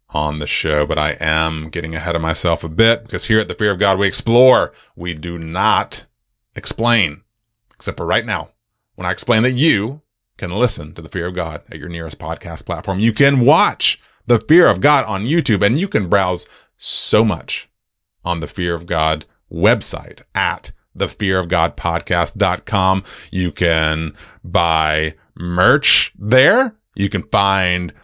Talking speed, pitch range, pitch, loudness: 165 wpm, 80-110 Hz, 90 Hz, -17 LUFS